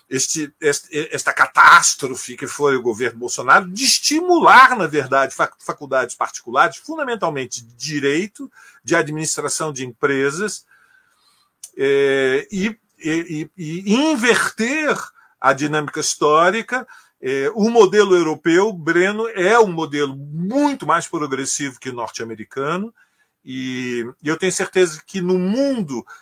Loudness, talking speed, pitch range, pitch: -17 LUFS, 115 wpm, 145-235 Hz, 175 Hz